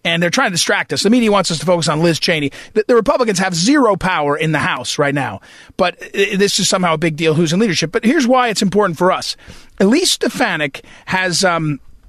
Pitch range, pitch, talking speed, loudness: 165-215 Hz, 185 Hz, 230 wpm, -15 LUFS